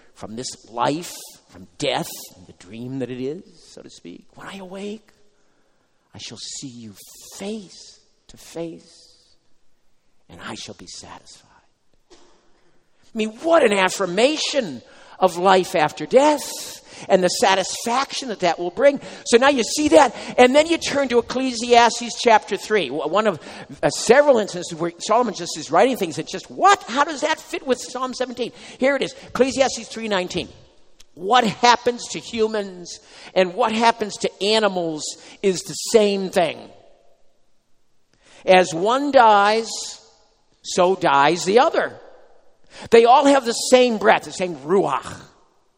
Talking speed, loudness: 150 wpm, -19 LUFS